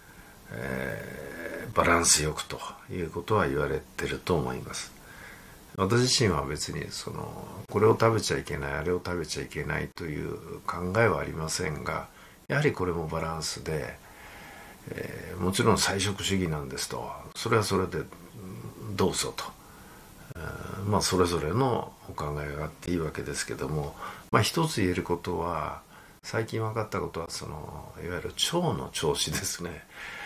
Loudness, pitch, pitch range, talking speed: -29 LUFS, 90 Hz, 80-100 Hz, 320 characters per minute